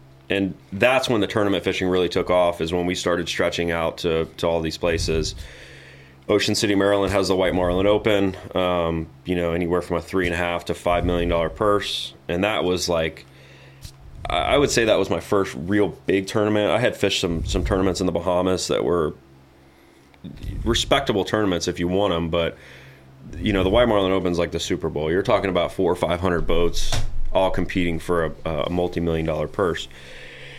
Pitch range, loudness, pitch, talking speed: 80-95 Hz, -22 LUFS, 85 Hz, 195 wpm